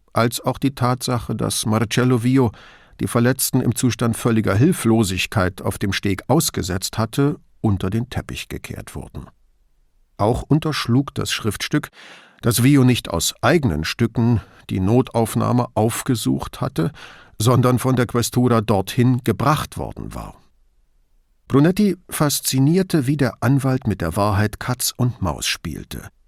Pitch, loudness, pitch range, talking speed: 120 Hz, -19 LUFS, 110-130 Hz, 130 wpm